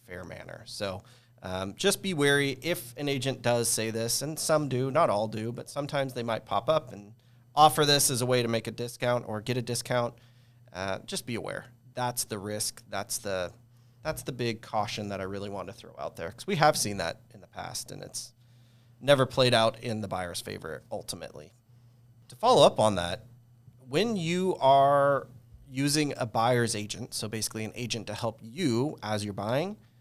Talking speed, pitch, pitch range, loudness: 200 wpm, 120 Hz, 110-130 Hz, -28 LUFS